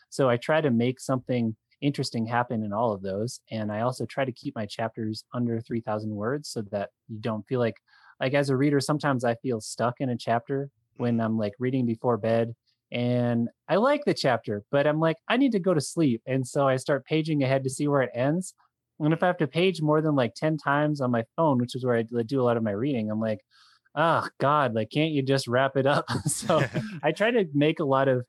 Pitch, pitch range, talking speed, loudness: 130 Hz, 115-145 Hz, 240 wpm, -26 LUFS